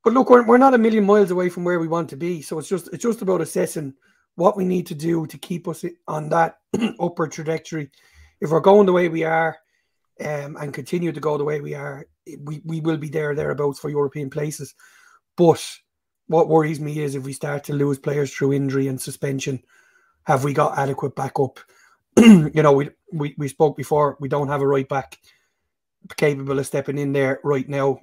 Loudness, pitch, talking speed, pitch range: -20 LUFS, 155 Hz, 210 wpm, 140-175 Hz